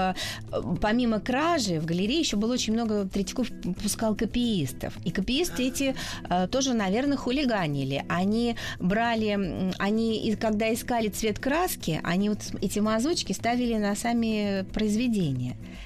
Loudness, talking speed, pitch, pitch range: -27 LUFS, 120 wpm, 215 Hz, 190-240 Hz